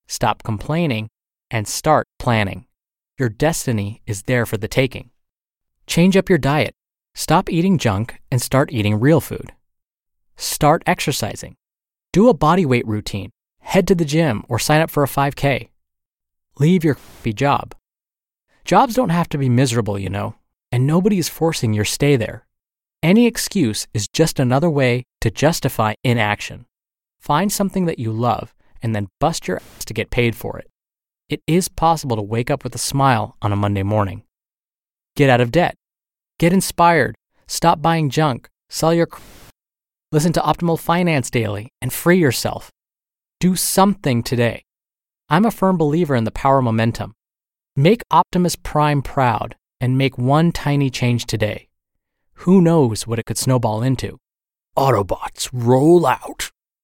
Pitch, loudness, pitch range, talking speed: 130 Hz, -18 LUFS, 110-165 Hz, 155 wpm